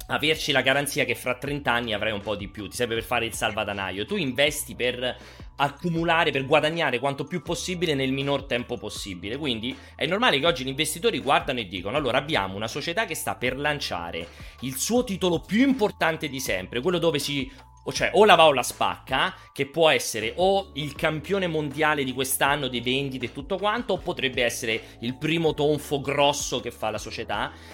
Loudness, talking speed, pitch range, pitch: -25 LUFS, 195 wpm, 120-160 Hz, 140 Hz